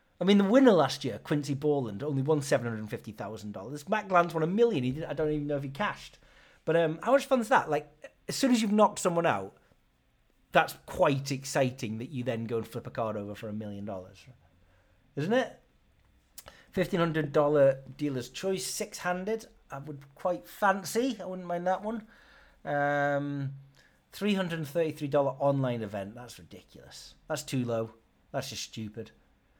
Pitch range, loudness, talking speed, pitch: 120-180 Hz, -30 LUFS, 195 wpm, 145 Hz